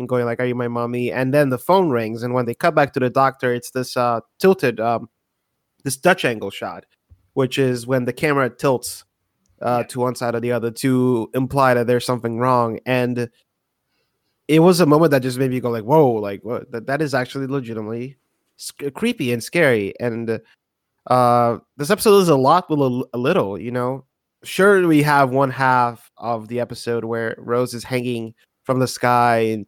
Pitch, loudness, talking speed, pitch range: 125 Hz, -19 LUFS, 205 wpm, 120-135 Hz